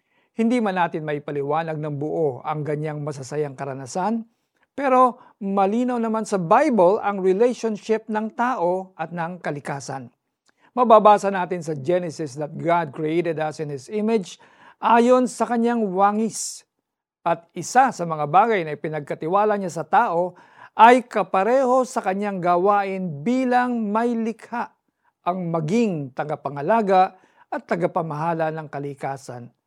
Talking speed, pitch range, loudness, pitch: 125 wpm, 155-220 Hz, -22 LUFS, 185 Hz